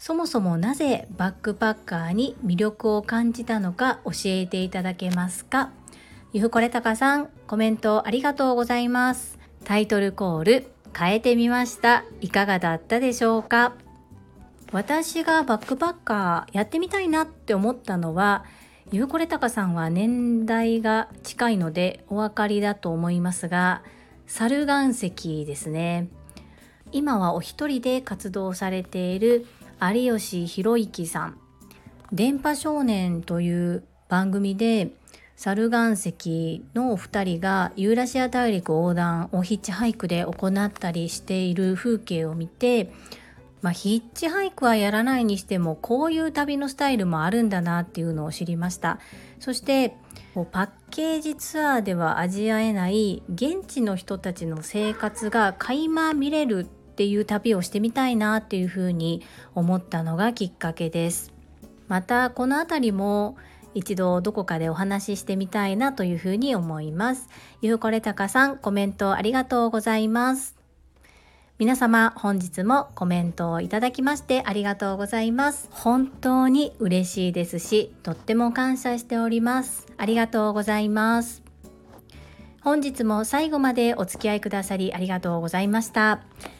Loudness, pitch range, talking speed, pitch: -24 LUFS, 180-240 Hz, 315 characters per minute, 210 Hz